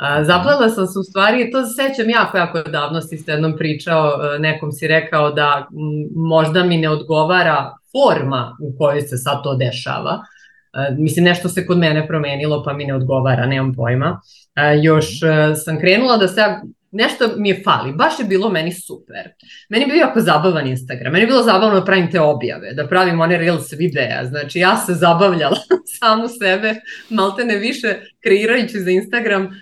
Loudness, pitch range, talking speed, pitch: -16 LUFS, 150-205 Hz, 185 wpm, 170 Hz